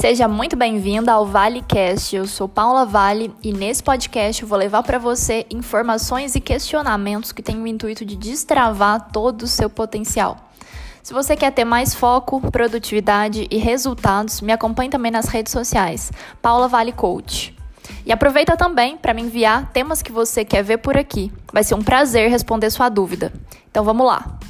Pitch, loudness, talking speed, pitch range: 230 Hz, -18 LUFS, 175 wpm, 215-250 Hz